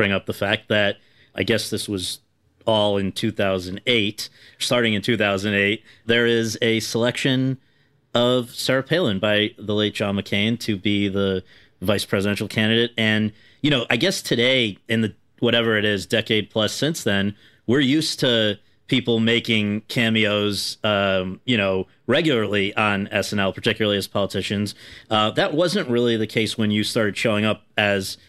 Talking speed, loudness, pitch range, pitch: 160 wpm, -21 LUFS, 100-120 Hz, 110 Hz